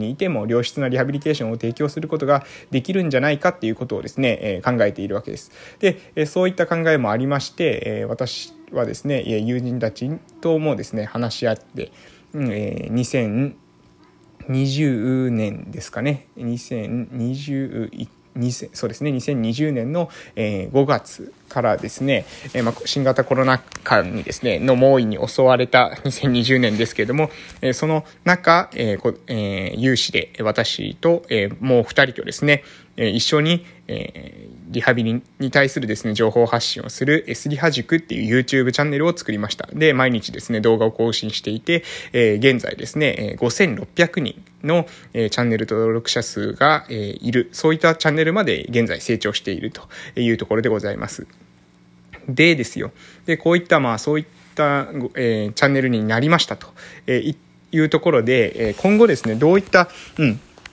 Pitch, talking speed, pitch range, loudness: 130 Hz, 310 characters per minute, 115-155 Hz, -20 LUFS